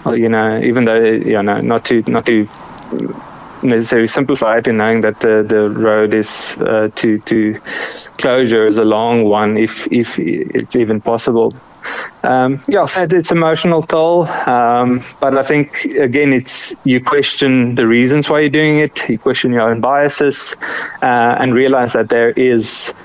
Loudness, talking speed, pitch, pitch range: -13 LUFS, 170 wpm, 120 Hz, 110-140 Hz